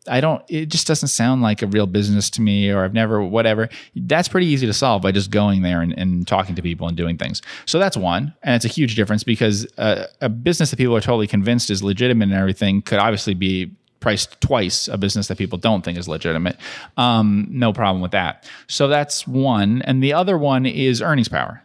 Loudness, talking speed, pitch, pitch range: -19 LUFS, 225 wpm, 110 Hz, 100-130 Hz